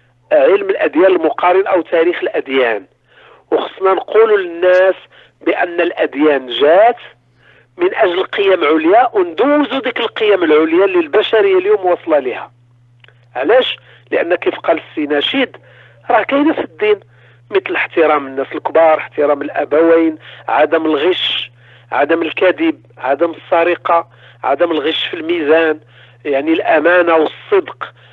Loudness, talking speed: -13 LUFS, 110 wpm